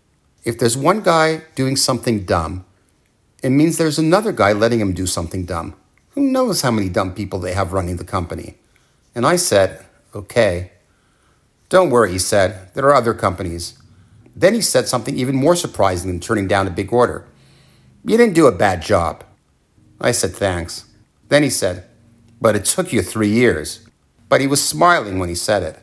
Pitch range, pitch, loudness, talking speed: 95-135 Hz, 110 Hz, -17 LUFS, 185 wpm